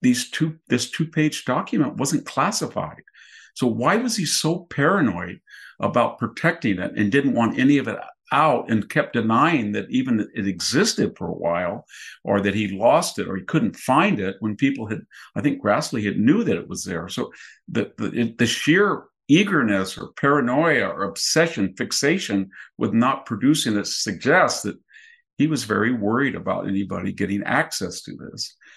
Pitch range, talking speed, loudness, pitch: 100-165 Hz, 175 wpm, -22 LUFS, 120 Hz